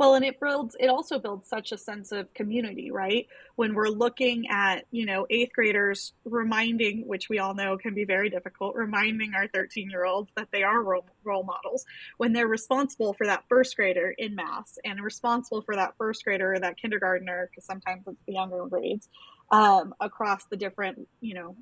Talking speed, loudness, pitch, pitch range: 195 wpm, -27 LUFS, 210 Hz, 195-235 Hz